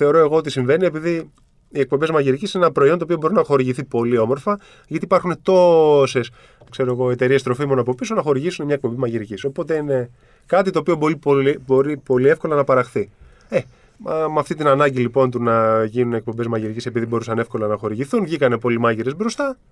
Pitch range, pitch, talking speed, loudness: 120-160 Hz, 135 Hz, 190 wpm, -19 LUFS